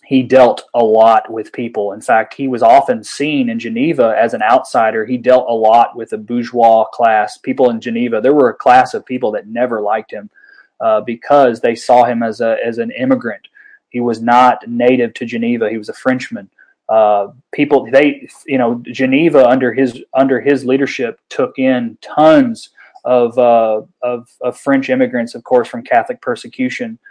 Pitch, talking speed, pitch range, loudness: 130 Hz, 185 wpm, 120-170 Hz, -13 LUFS